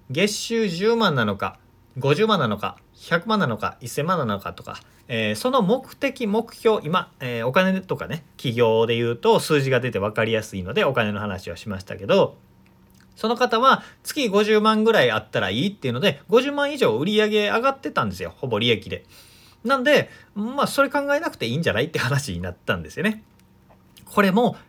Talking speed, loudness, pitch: 340 characters per minute, -22 LUFS, 190 Hz